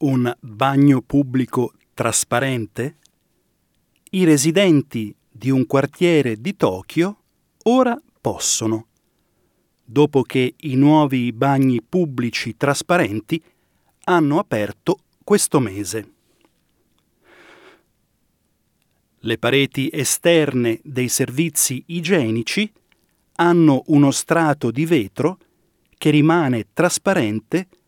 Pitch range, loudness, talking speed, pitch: 125-170 Hz, -18 LUFS, 80 wpm, 140 Hz